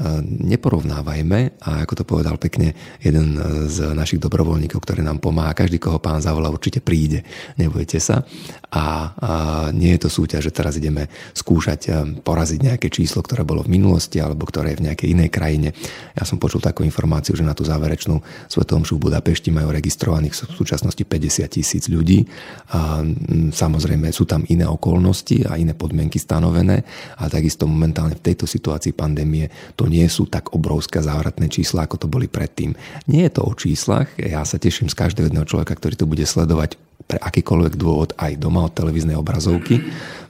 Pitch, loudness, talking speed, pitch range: 80 Hz, -19 LUFS, 170 wpm, 75-90 Hz